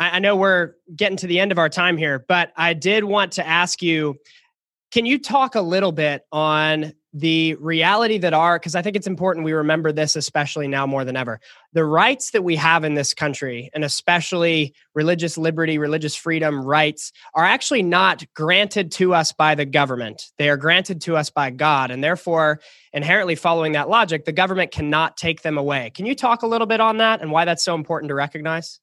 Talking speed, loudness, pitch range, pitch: 210 wpm, -19 LUFS, 150-185 Hz, 165 Hz